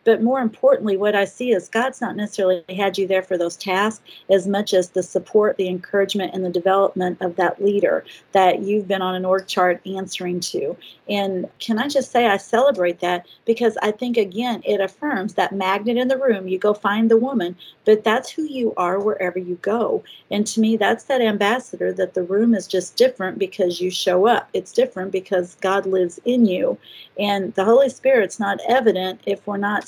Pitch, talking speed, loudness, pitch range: 200 Hz, 205 wpm, -20 LUFS, 185-225 Hz